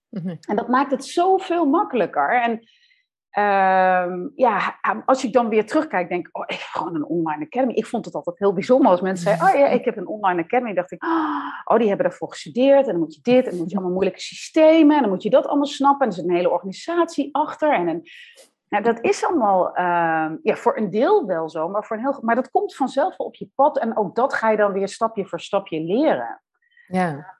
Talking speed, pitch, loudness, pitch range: 240 wpm, 230 Hz, -20 LUFS, 190-290 Hz